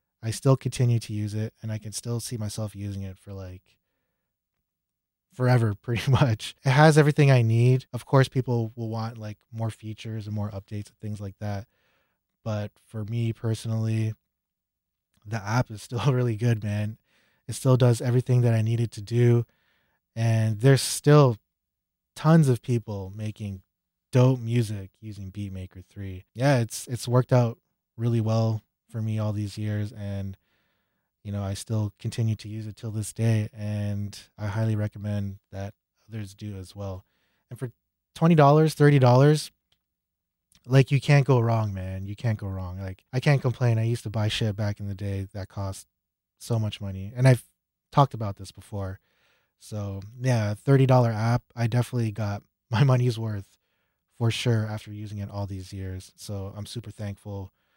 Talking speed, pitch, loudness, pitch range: 170 wpm, 110 Hz, -25 LUFS, 100-120 Hz